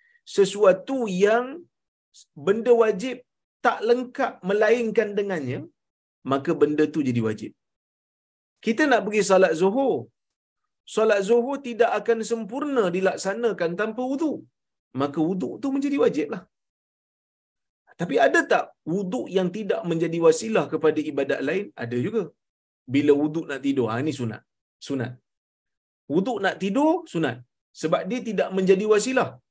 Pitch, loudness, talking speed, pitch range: 195 Hz, -23 LUFS, 125 wpm, 155-235 Hz